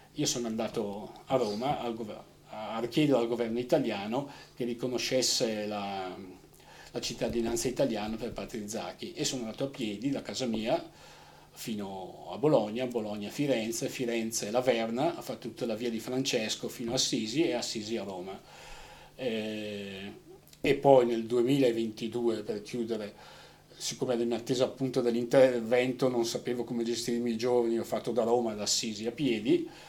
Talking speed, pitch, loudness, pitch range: 150 wpm, 120 Hz, -31 LUFS, 110-125 Hz